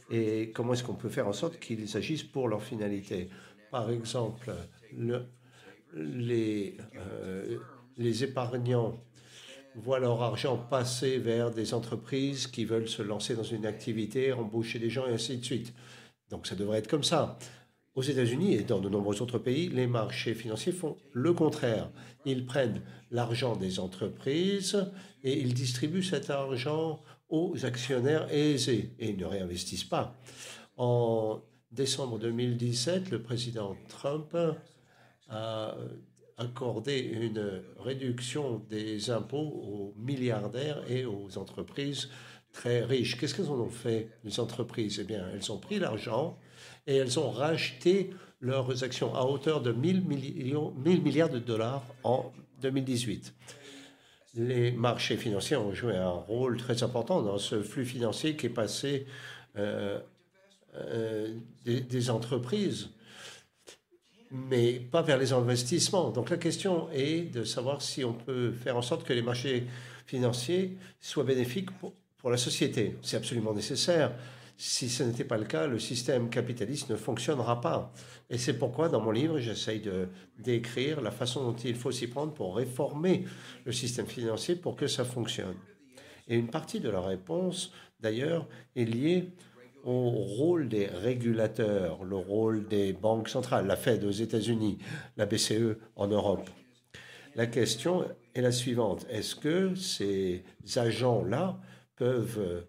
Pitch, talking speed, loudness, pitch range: 120 Hz, 145 wpm, -32 LUFS, 110-140 Hz